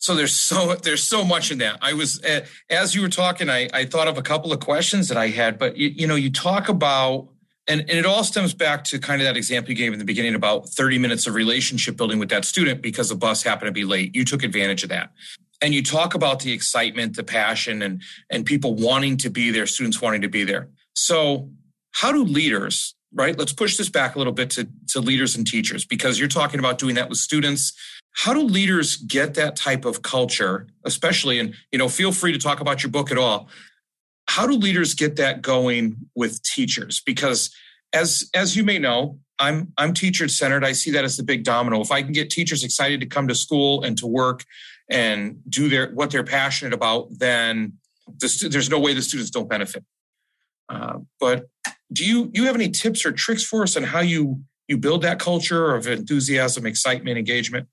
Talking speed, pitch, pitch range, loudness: 220 wpm, 140 Hz, 125-165 Hz, -20 LUFS